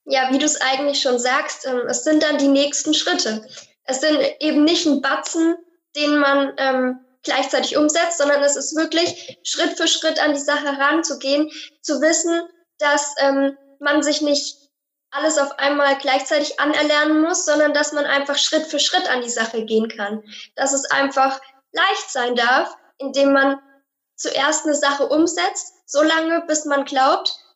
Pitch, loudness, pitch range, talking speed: 285 Hz, -18 LUFS, 275-305 Hz, 170 wpm